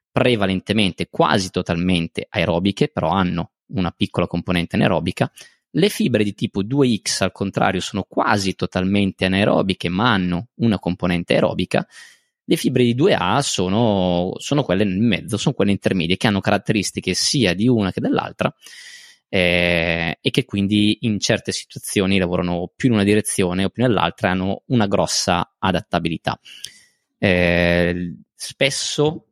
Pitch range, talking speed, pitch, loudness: 90-110 Hz, 140 wpm, 95 Hz, -19 LUFS